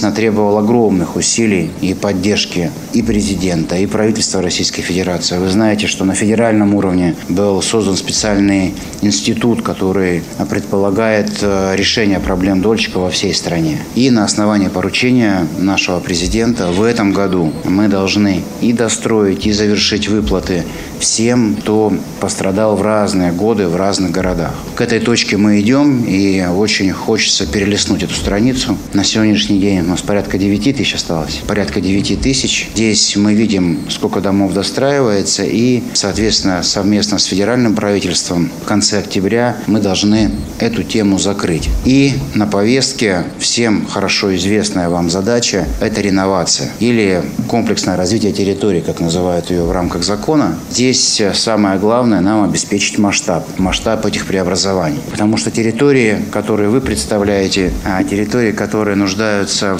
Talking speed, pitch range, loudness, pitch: 135 wpm, 95-110 Hz, -13 LUFS, 100 Hz